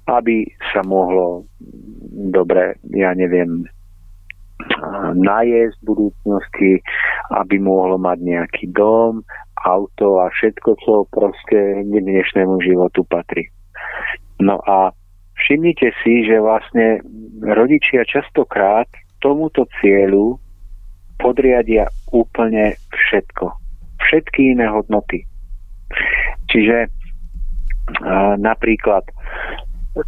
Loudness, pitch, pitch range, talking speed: -16 LUFS, 95 Hz, 90-110 Hz, 80 wpm